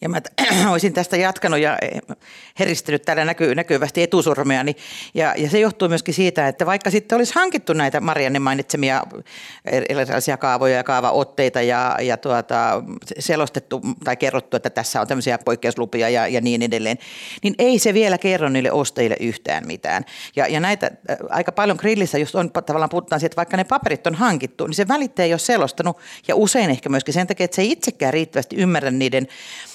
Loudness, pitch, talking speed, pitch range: -19 LUFS, 165 Hz, 180 wpm, 135-190 Hz